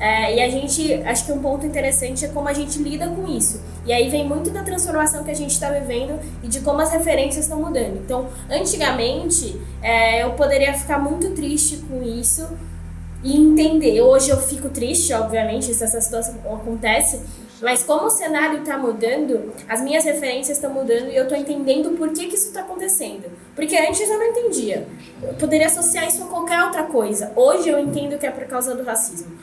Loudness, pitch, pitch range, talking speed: -19 LUFS, 285 Hz, 240-315 Hz, 200 wpm